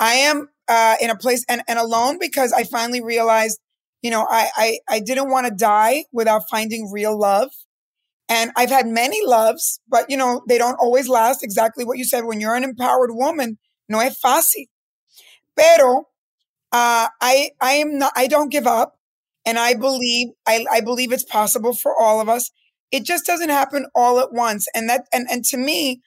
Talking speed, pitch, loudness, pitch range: 195 wpm, 245 Hz, -18 LUFS, 230-265 Hz